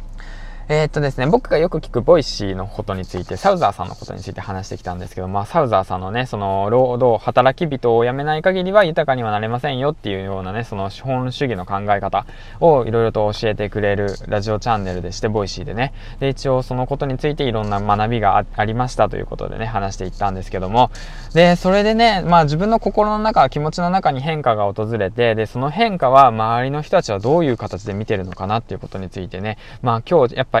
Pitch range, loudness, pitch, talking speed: 100-135 Hz, -18 LUFS, 115 Hz, 470 characters per minute